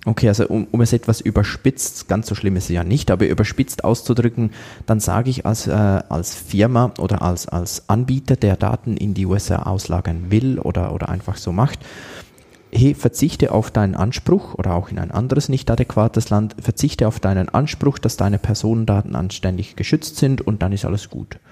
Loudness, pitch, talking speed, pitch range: -19 LUFS, 110 Hz, 190 wpm, 95-120 Hz